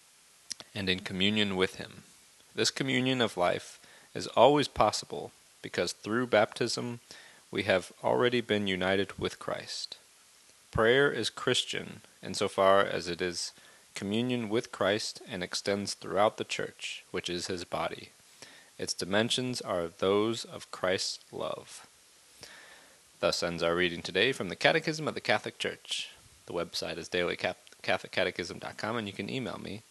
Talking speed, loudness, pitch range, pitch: 140 wpm, -30 LUFS, 90-115 Hz, 100 Hz